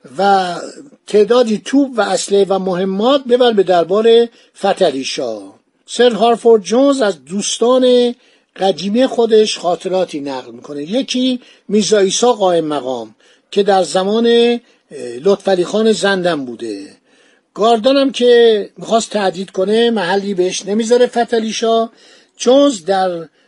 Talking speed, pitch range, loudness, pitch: 110 wpm, 185-240 Hz, -14 LUFS, 210 Hz